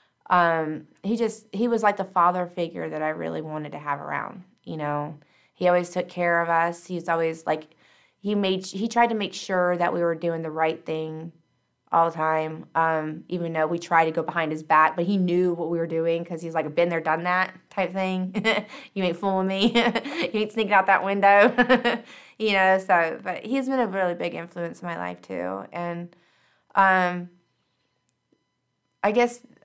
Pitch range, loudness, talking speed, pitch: 165-195 Hz, -24 LUFS, 200 wpm, 175 Hz